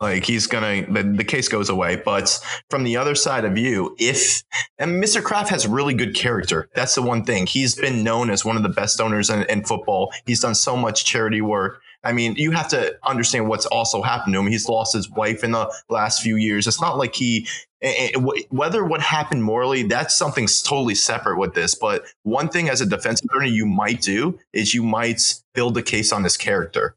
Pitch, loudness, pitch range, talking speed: 115 Hz, -20 LUFS, 110-130 Hz, 220 wpm